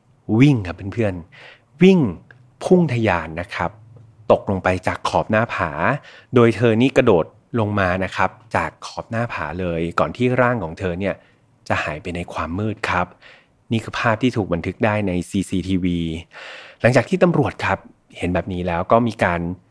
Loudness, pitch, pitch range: -20 LUFS, 100 Hz, 90-115 Hz